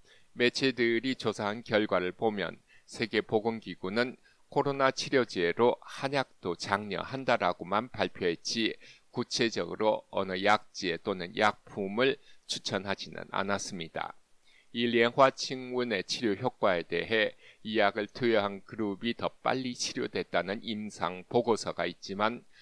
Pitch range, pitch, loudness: 100-125 Hz, 115 Hz, -31 LUFS